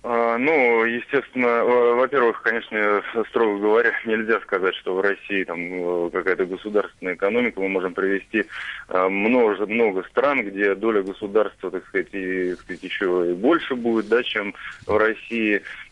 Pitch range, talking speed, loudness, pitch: 95-115 Hz, 135 wpm, -22 LUFS, 105 Hz